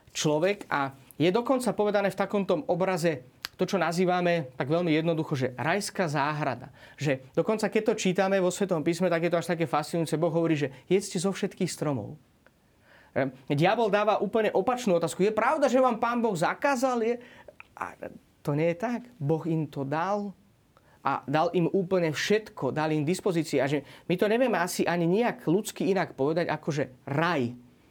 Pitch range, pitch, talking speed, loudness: 155-200 Hz, 175 Hz, 175 wpm, -27 LUFS